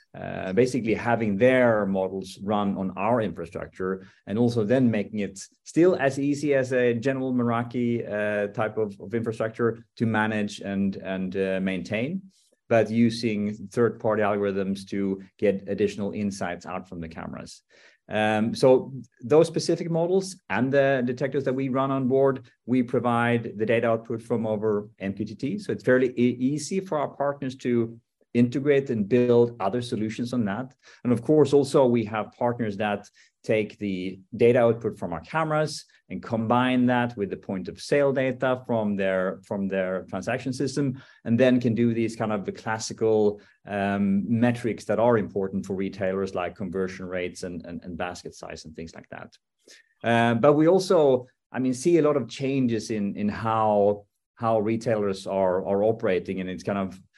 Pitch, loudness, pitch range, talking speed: 115 Hz, -25 LUFS, 100-125 Hz, 170 wpm